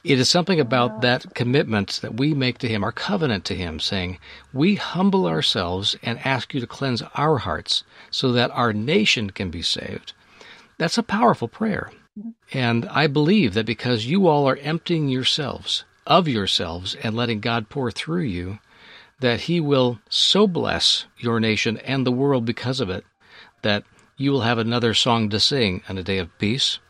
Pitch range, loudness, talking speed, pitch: 110-150 Hz, -21 LUFS, 180 wpm, 125 Hz